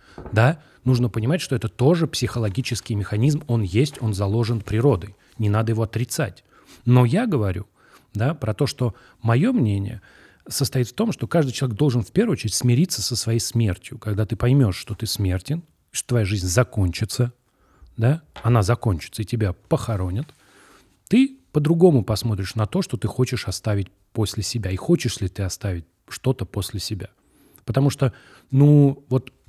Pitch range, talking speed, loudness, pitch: 105-130 Hz, 160 wpm, -22 LUFS, 115 Hz